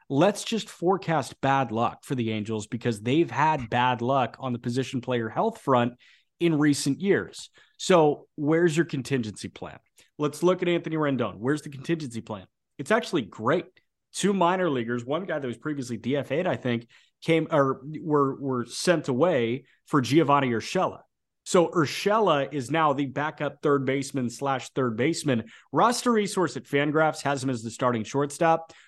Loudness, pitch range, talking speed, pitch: -26 LUFS, 125-165 Hz, 165 wpm, 140 Hz